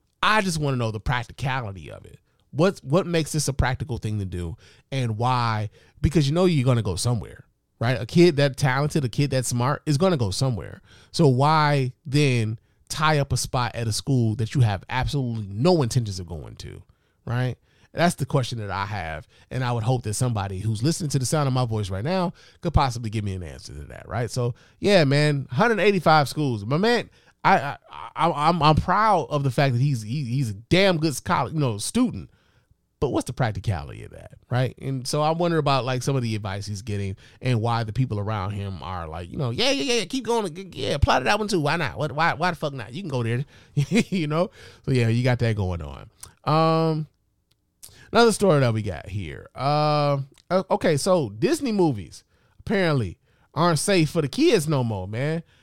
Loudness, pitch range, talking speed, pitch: -23 LUFS, 110-160 Hz, 215 wpm, 130 Hz